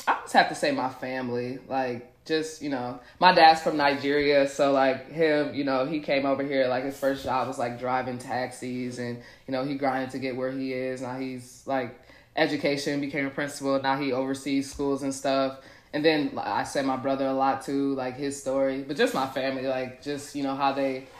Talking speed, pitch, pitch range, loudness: 220 wpm, 135 Hz, 130-140 Hz, -27 LUFS